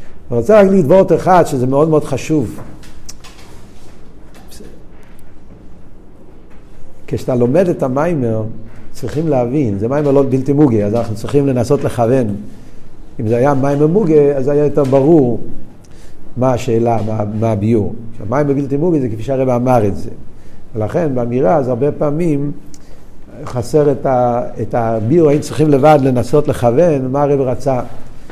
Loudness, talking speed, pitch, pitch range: -14 LUFS, 140 wpm, 130 Hz, 115-145 Hz